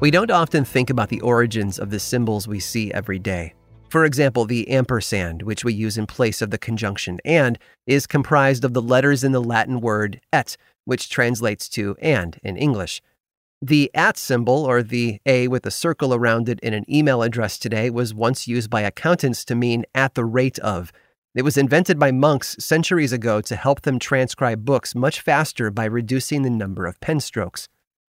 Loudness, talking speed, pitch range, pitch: -20 LUFS, 195 wpm, 110-135 Hz, 120 Hz